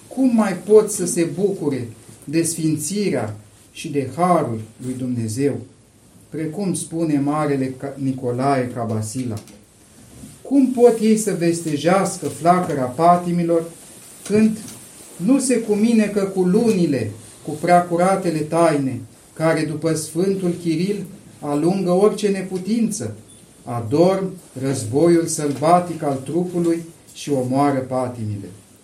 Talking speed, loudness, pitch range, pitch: 100 wpm, -20 LUFS, 130-185 Hz, 160 Hz